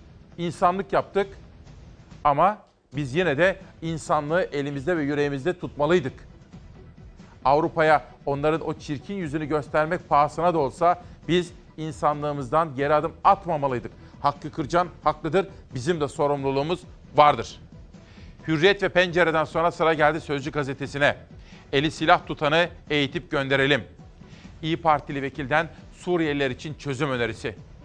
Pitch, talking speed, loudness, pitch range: 155 Hz, 110 wpm, -24 LUFS, 140-170 Hz